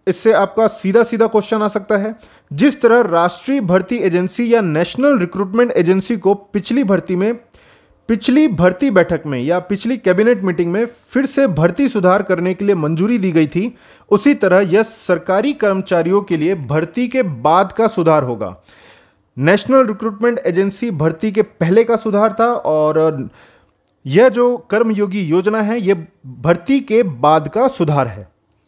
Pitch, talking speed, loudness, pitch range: 200 Hz, 160 wpm, -15 LUFS, 170-230 Hz